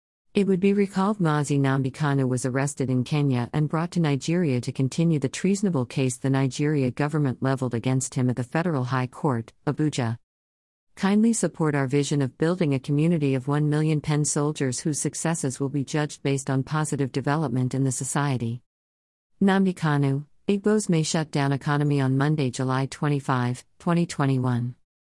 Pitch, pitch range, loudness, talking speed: 140 Hz, 130-155 Hz, -25 LUFS, 160 wpm